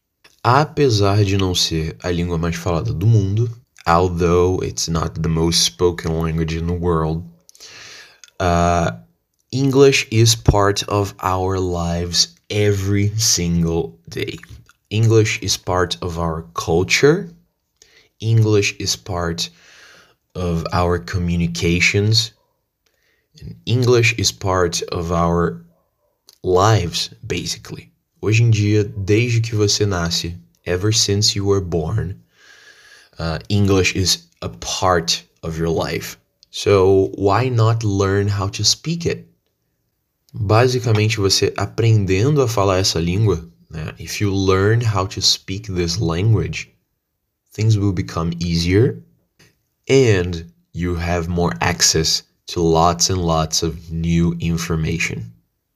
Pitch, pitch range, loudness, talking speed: 95 Hz, 85-105 Hz, -18 LUFS, 120 wpm